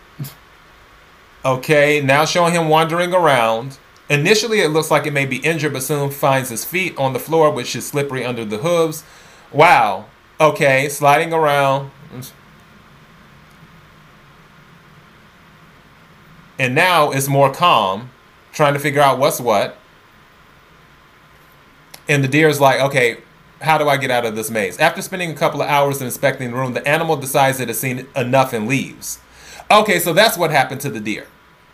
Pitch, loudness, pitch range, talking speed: 140 Hz, -16 LUFS, 130-155 Hz, 155 wpm